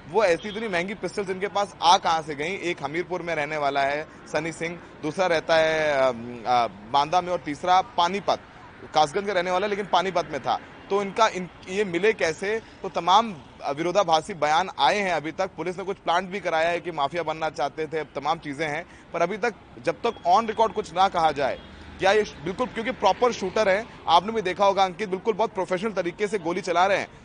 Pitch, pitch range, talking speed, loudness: 180 Hz, 160-205 Hz, 220 wpm, -25 LUFS